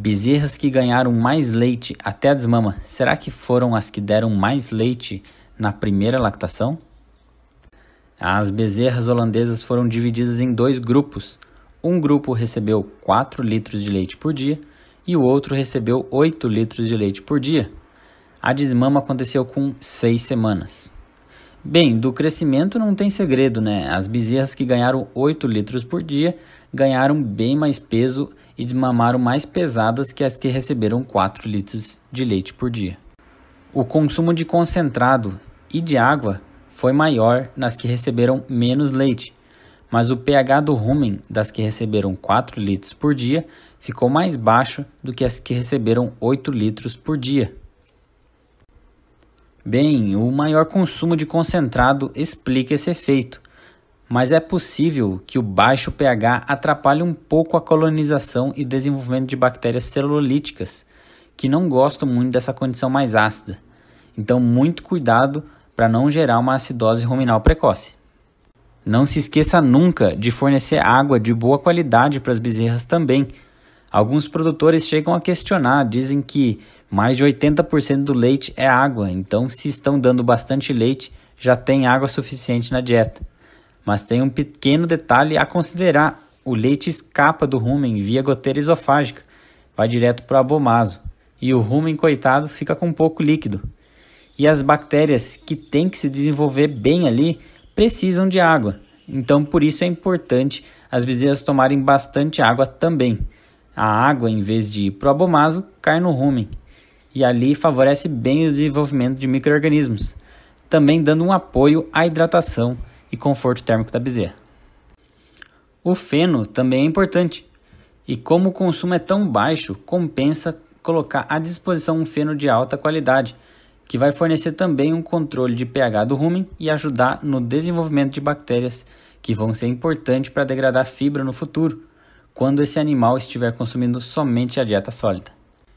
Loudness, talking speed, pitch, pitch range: -18 LUFS, 150 wpm, 130 Hz, 120-150 Hz